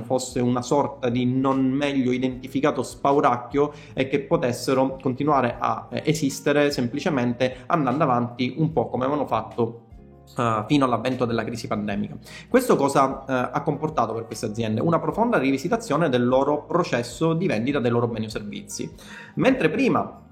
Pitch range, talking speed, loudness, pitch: 120-145 Hz, 150 wpm, -23 LUFS, 130 Hz